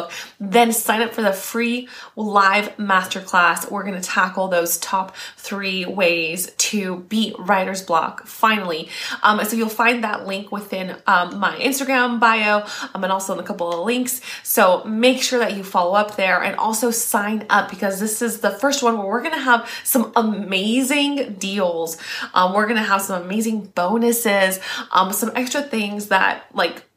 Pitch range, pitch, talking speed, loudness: 190-235 Hz, 205 Hz, 170 wpm, -19 LUFS